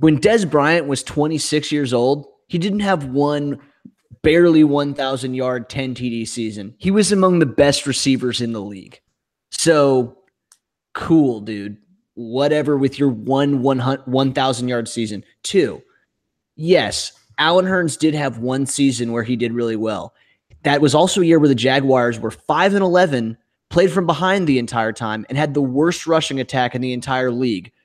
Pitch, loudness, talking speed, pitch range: 135 Hz, -18 LUFS, 160 wpm, 120-155 Hz